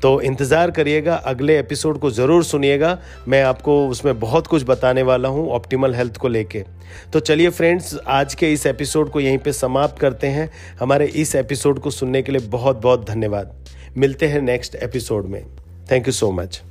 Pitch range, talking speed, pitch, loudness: 125-150 Hz, 185 wpm, 135 Hz, -18 LUFS